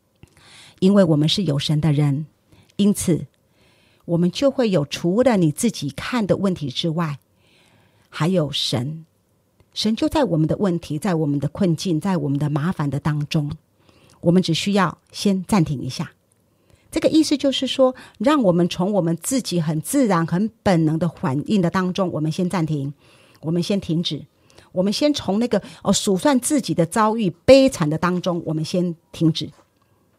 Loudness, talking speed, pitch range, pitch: -20 LUFS, 245 characters per minute, 150-195 Hz, 170 Hz